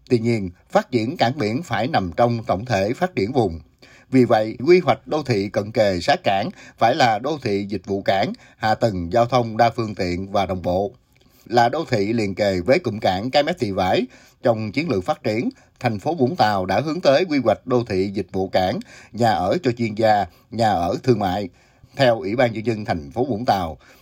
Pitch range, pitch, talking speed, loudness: 100-125 Hz, 115 Hz, 225 wpm, -21 LUFS